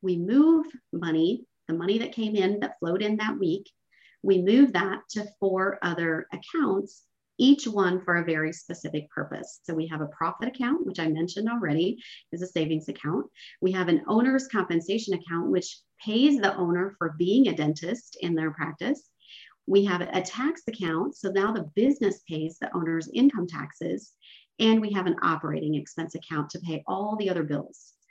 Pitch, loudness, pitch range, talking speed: 185 Hz, -27 LUFS, 165-220 Hz, 180 wpm